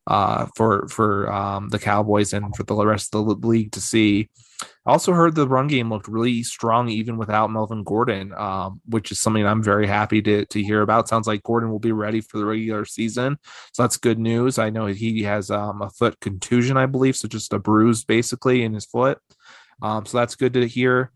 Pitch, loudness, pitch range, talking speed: 110 Hz, -21 LUFS, 105-120 Hz, 220 wpm